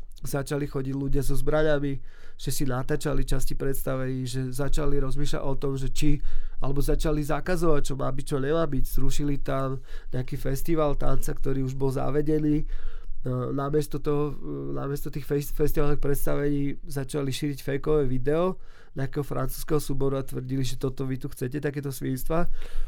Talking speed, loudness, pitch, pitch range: 145 wpm, -29 LUFS, 140 Hz, 135-150 Hz